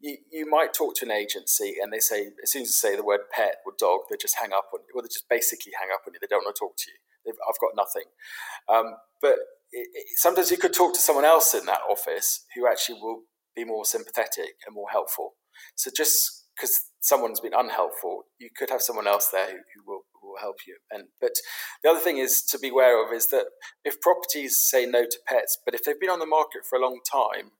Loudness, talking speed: -24 LUFS, 250 wpm